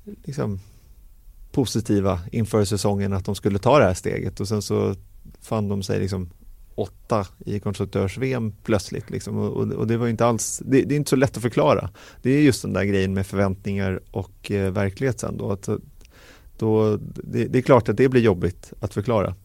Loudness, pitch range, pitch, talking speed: -23 LUFS, 100-120 Hz, 105 Hz, 190 wpm